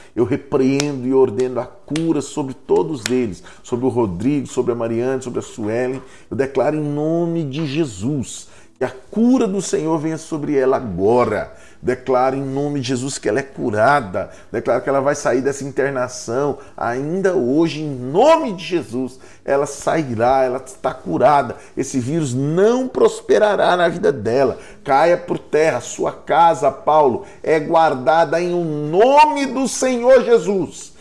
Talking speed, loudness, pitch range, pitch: 155 wpm, -18 LUFS, 130-170 Hz, 145 Hz